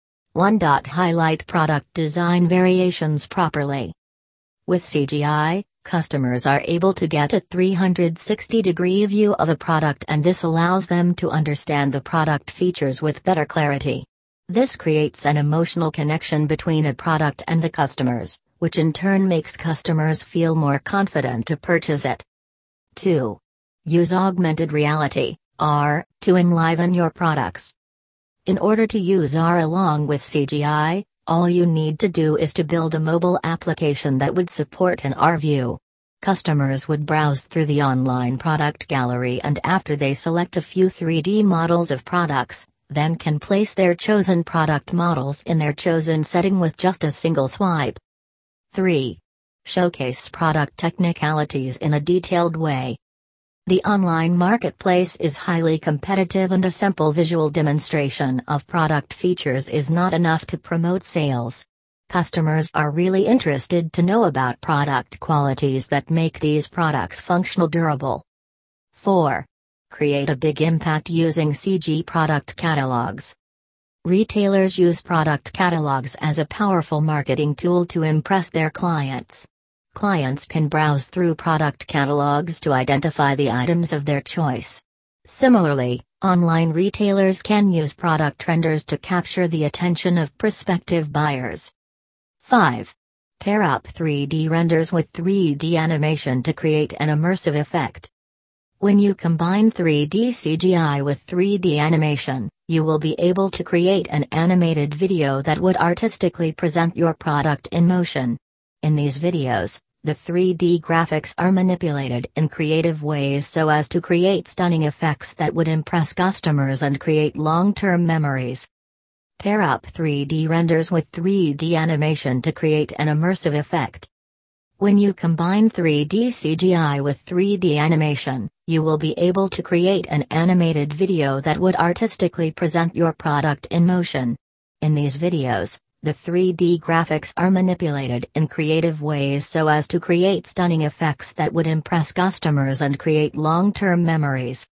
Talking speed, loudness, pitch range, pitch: 140 wpm, -20 LUFS, 145-175 Hz, 160 Hz